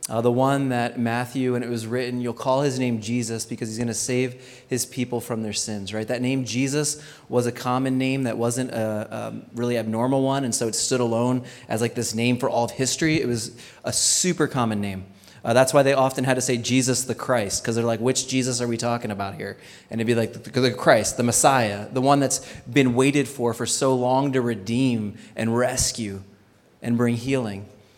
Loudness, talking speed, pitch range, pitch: -23 LUFS, 220 wpm, 115-130 Hz, 120 Hz